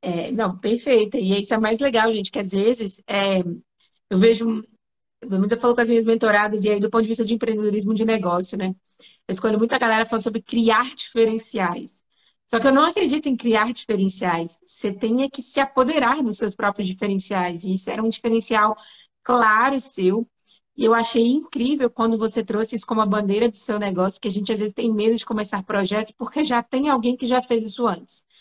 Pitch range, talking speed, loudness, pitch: 210-235 Hz, 205 wpm, -21 LUFS, 225 Hz